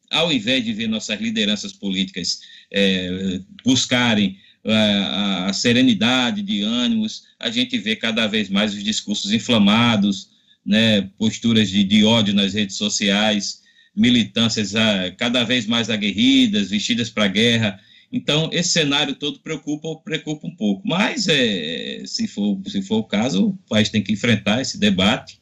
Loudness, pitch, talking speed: -19 LUFS, 190 Hz, 150 wpm